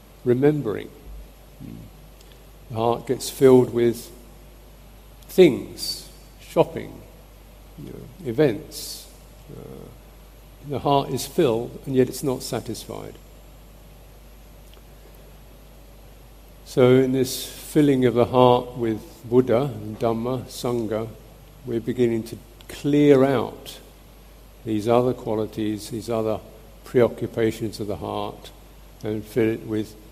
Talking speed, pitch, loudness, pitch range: 100 wpm, 120 Hz, -22 LUFS, 110-130 Hz